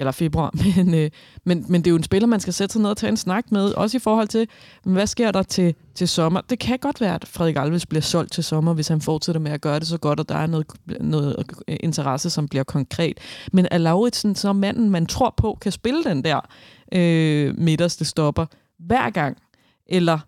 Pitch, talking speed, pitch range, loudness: 170 Hz, 230 wpm, 155-200 Hz, -21 LUFS